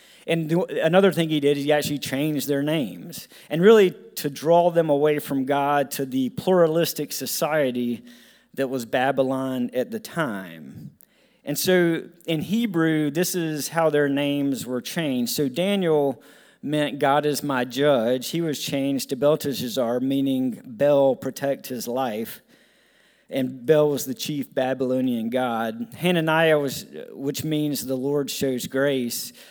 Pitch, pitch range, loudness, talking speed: 145 Hz, 135-165 Hz, -23 LUFS, 145 wpm